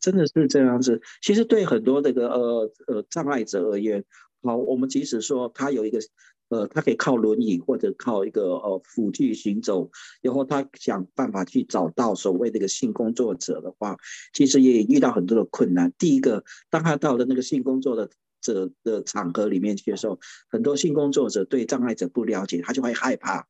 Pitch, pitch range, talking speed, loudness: 130 Hz, 120-155 Hz, 300 characters per minute, -23 LUFS